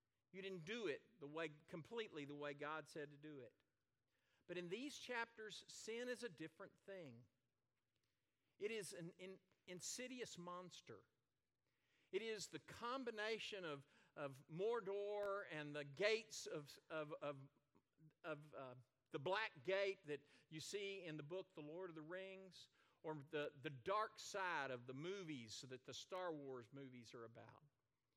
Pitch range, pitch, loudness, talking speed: 135-195 Hz, 155 Hz, -51 LUFS, 155 wpm